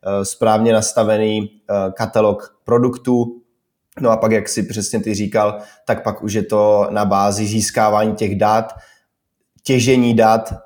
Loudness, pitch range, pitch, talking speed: -16 LUFS, 105-115 Hz, 110 Hz, 135 wpm